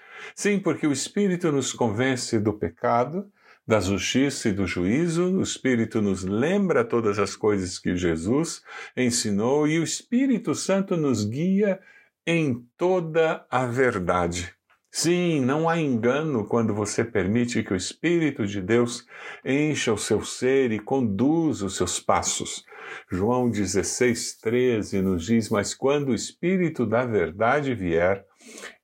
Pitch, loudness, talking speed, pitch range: 125 Hz, -24 LUFS, 135 wpm, 105-160 Hz